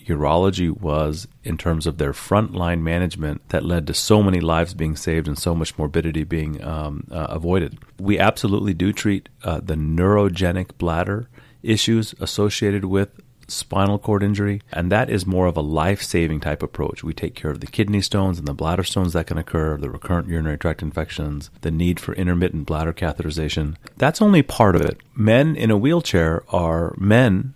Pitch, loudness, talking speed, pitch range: 90 Hz, -21 LUFS, 185 wpm, 80-100 Hz